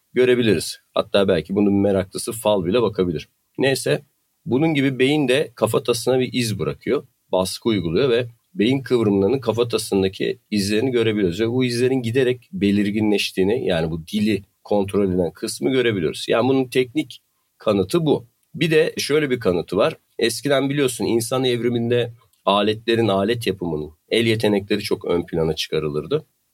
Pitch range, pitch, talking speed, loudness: 100-125 Hz, 115 Hz, 140 wpm, -20 LUFS